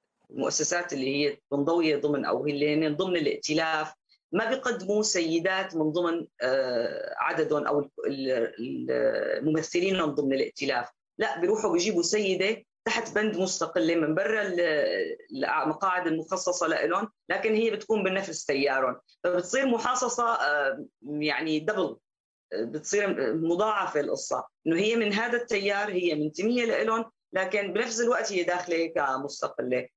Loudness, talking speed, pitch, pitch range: -27 LUFS, 120 wpm, 180 Hz, 155-215 Hz